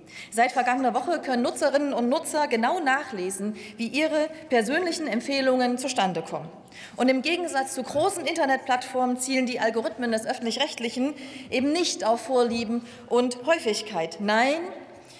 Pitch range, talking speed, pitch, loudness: 230-285 Hz, 135 wpm, 255 Hz, -25 LUFS